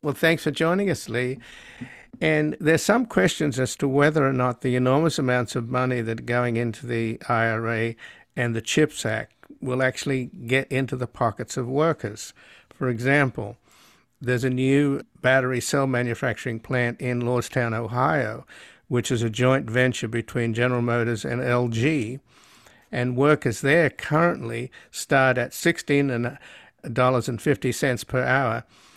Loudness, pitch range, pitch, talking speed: -23 LUFS, 120-140 Hz, 125 Hz, 145 wpm